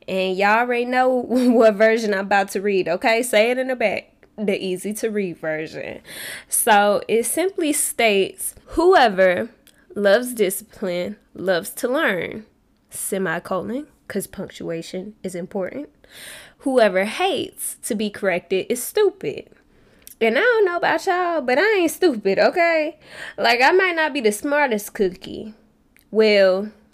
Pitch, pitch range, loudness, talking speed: 220 Hz, 195-285 Hz, -20 LUFS, 140 wpm